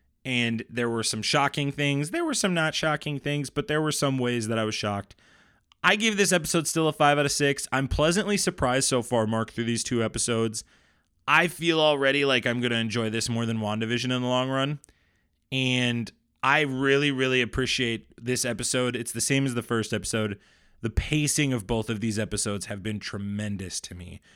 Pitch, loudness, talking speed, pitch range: 120 Hz, -25 LUFS, 205 wpm, 110-140 Hz